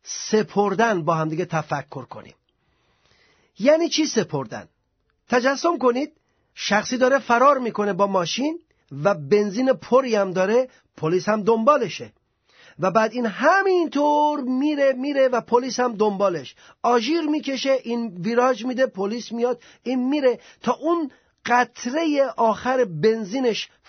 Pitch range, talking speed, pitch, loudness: 205-270 Hz, 125 wpm, 240 Hz, -21 LUFS